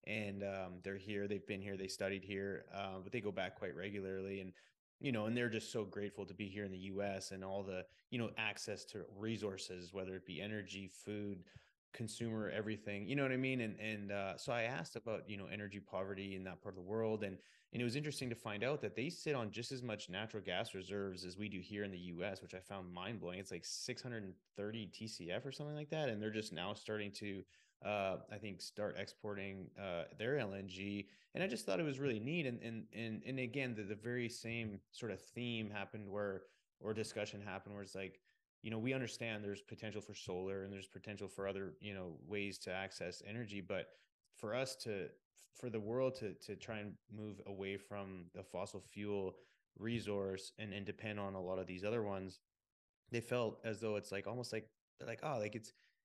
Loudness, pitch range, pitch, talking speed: -45 LUFS, 95-110 Hz, 100 Hz, 225 wpm